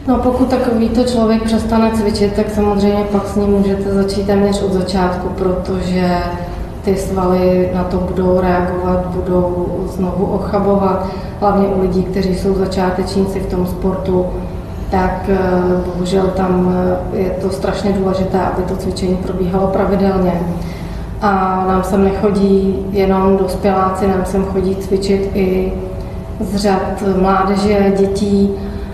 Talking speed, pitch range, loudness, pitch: 130 wpm, 185-200 Hz, -15 LUFS, 190 Hz